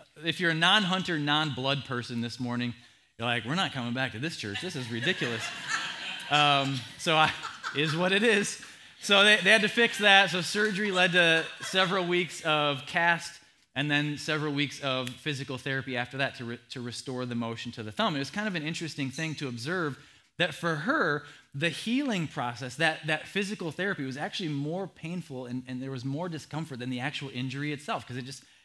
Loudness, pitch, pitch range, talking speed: -28 LUFS, 150 Hz, 130-175 Hz, 205 wpm